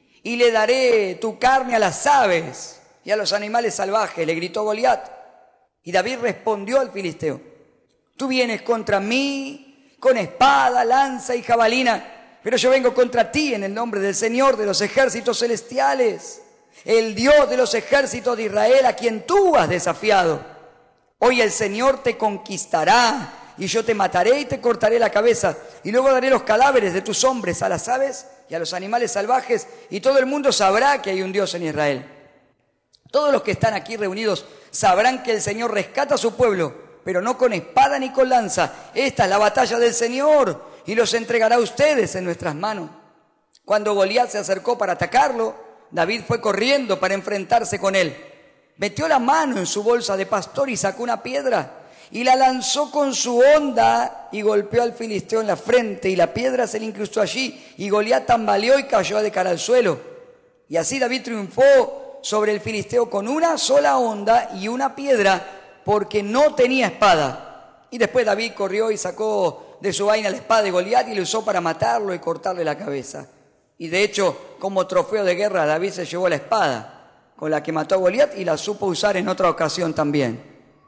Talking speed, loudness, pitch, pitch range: 185 wpm, -19 LUFS, 225 Hz, 195-260 Hz